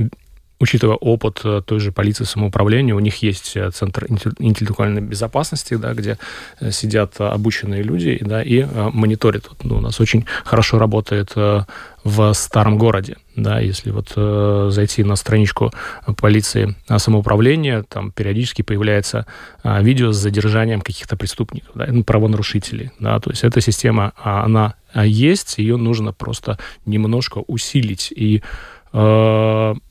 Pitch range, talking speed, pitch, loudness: 105-115 Hz, 130 wpm, 110 Hz, -17 LUFS